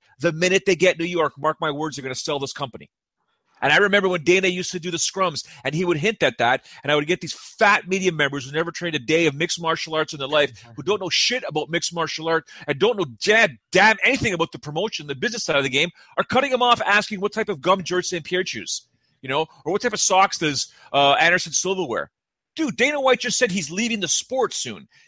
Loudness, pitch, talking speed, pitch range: -21 LUFS, 175 Hz, 260 wpm, 155-195 Hz